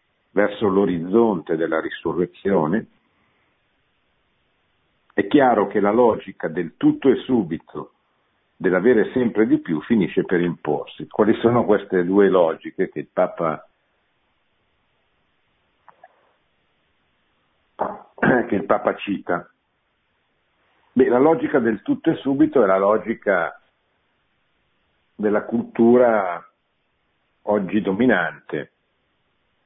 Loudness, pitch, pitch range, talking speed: -20 LUFS, 115 Hz, 100-130 Hz, 95 wpm